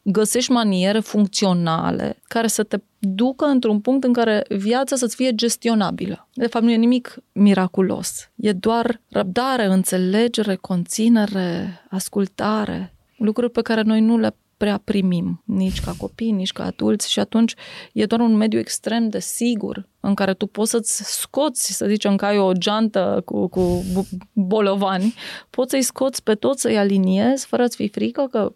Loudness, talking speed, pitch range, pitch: -20 LUFS, 160 wpm, 195-235 Hz, 215 Hz